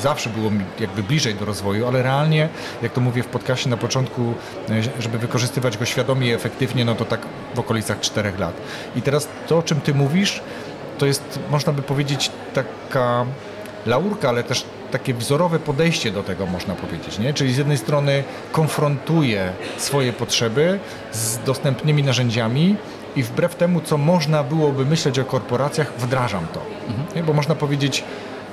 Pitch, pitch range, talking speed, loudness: 130 Hz, 120-150 Hz, 160 wpm, -21 LUFS